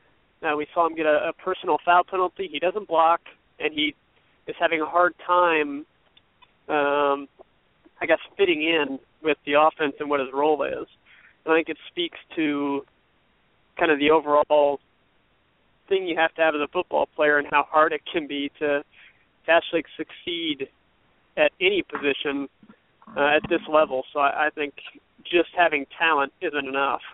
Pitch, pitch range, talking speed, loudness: 155 Hz, 145-170 Hz, 170 wpm, -23 LUFS